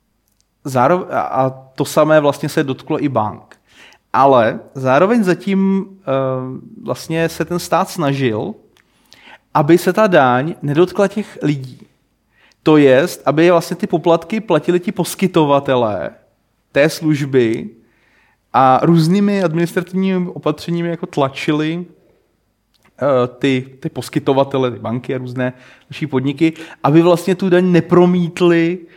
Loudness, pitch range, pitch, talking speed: -15 LUFS, 135-175 Hz, 160 Hz, 120 wpm